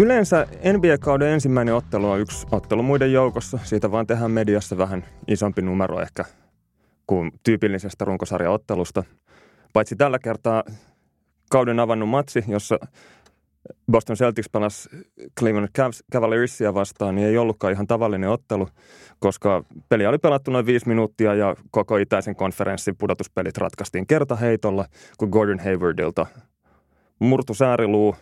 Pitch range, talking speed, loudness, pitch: 100-120 Hz, 125 wpm, -22 LUFS, 110 Hz